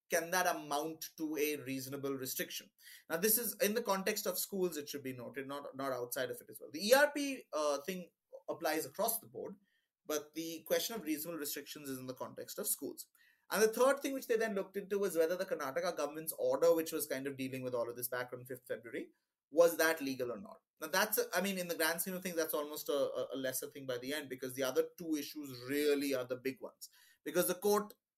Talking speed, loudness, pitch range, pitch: 240 wpm, -37 LUFS, 140-215 Hz, 165 Hz